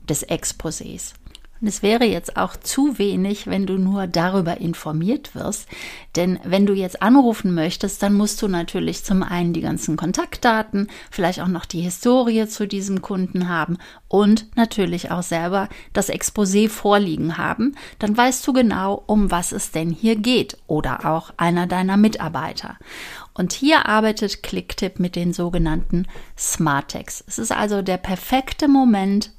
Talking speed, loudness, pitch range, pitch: 155 wpm, -20 LUFS, 175-220 Hz, 195 Hz